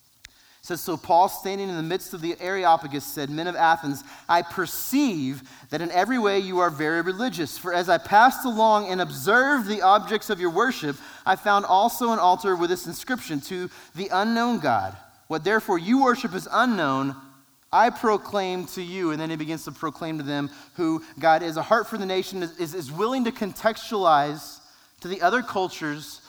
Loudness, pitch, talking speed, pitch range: -24 LUFS, 180 Hz, 190 wpm, 160-210 Hz